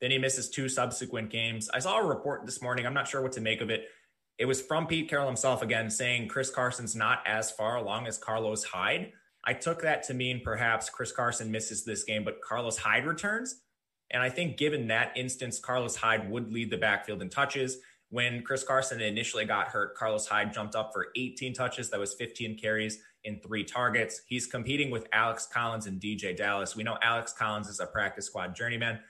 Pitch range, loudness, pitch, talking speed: 110-130 Hz, -31 LUFS, 120 Hz, 210 wpm